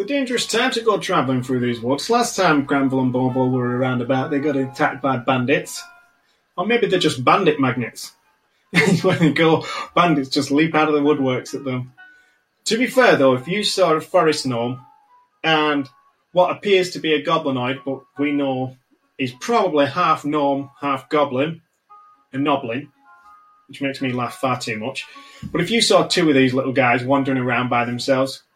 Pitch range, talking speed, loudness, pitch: 130-180 Hz, 185 wpm, -19 LUFS, 145 Hz